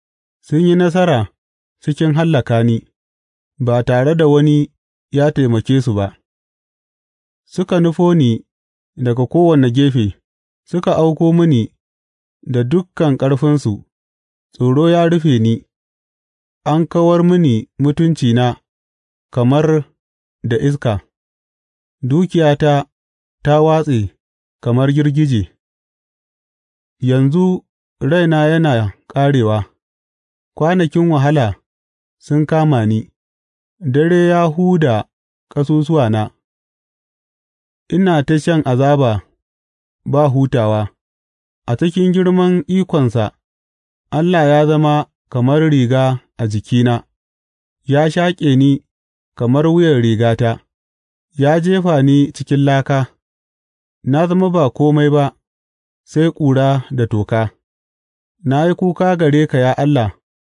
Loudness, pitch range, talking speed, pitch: -14 LUFS, 105-155 Hz, 95 wpm, 135 Hz